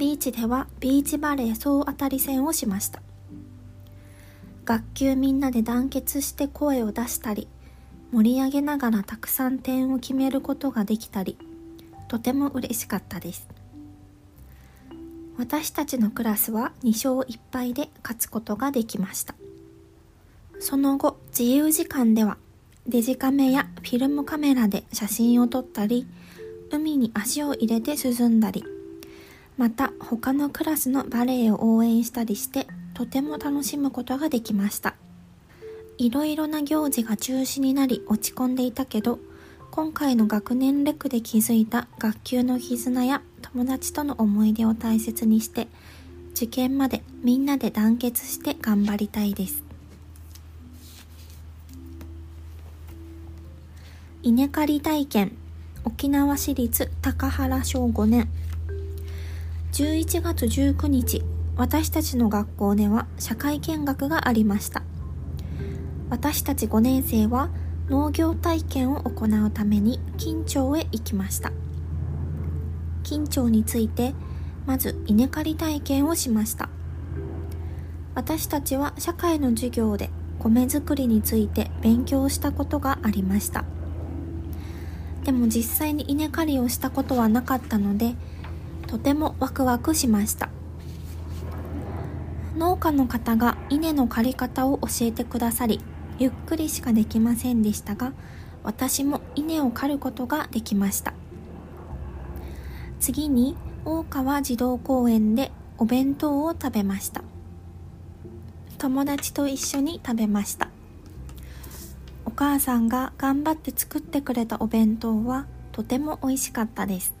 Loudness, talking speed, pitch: -25 LUFS, 245 characters per minute, 220 Hz